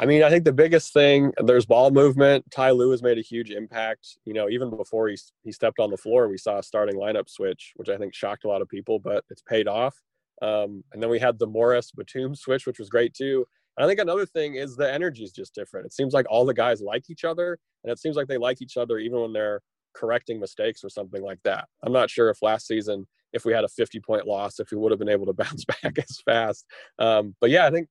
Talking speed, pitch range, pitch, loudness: 265 wpm, 115-165 Hz, 130 Hz, -23 LUFS